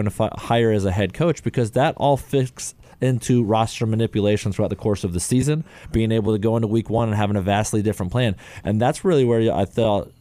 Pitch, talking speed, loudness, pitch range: 115 Hz, 225 wpm, -21 LUFS, 105-125 Hz